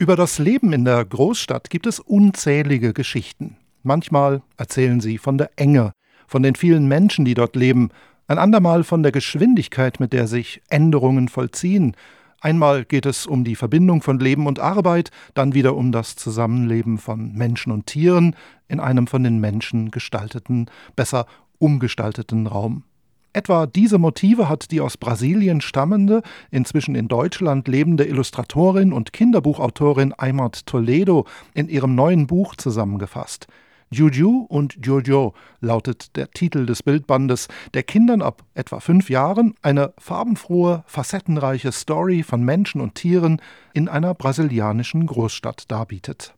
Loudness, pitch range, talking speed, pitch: -19 LUFS, 125-170 Hz, 140 wpm, 140 Hz